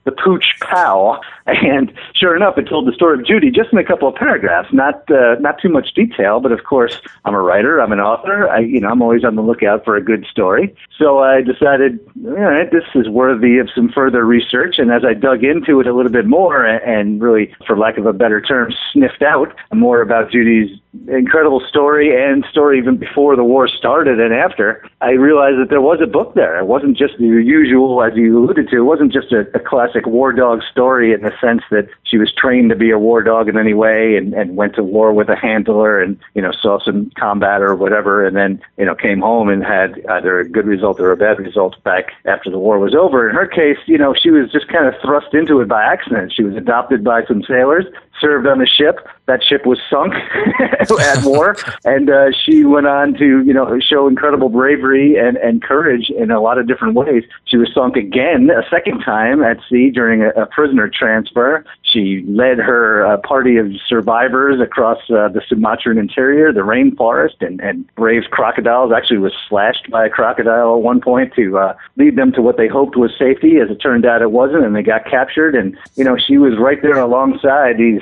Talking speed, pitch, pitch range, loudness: 220 wpm, 125 Hz, 115-145 Hz, -12 LUFS